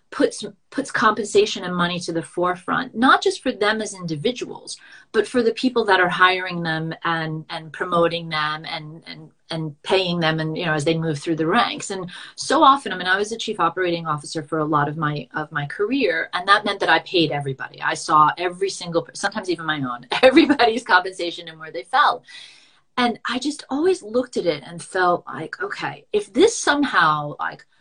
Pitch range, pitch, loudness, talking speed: 160-220 Hz, 180 Hz, -21 LUFS, 205 wpm